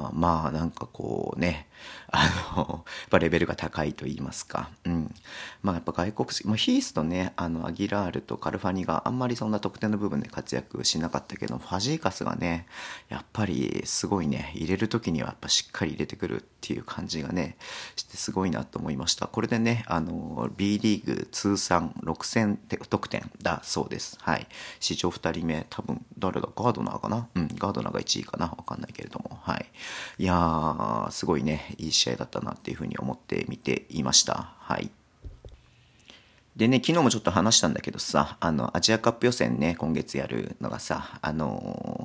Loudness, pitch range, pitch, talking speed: -28 LUFS, 80-110 Hz, 90 Hz, 375 characters per minute